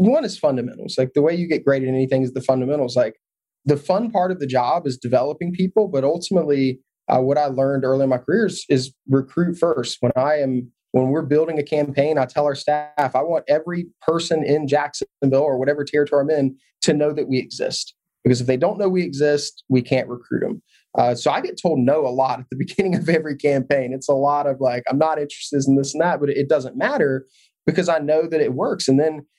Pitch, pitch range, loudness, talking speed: 145 Hz, 130-160 Hz, -20 LUFS, 235 wpm